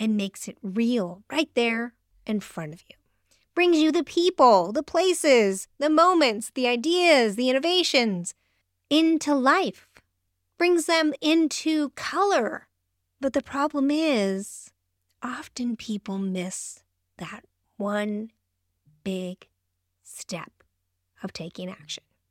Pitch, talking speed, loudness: 220 Hz, 115 wpm, -23 LUFS